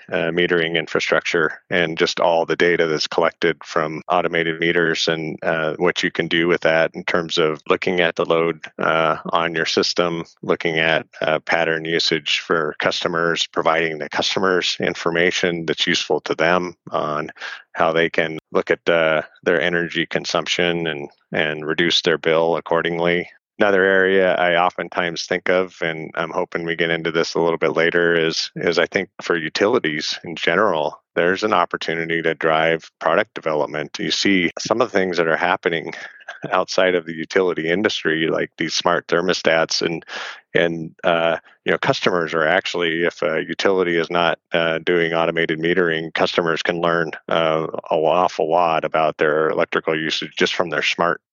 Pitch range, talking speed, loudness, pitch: 80-85 Hz, 170 wpm, -19 LUFS, 85 Hz